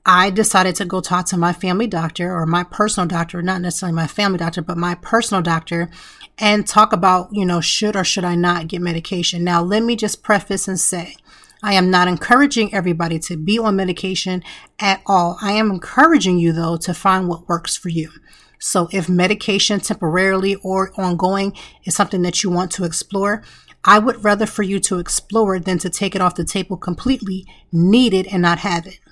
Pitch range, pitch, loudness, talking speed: 175-200 Hz, 185 Hz, -17 LUFS, 200 wpm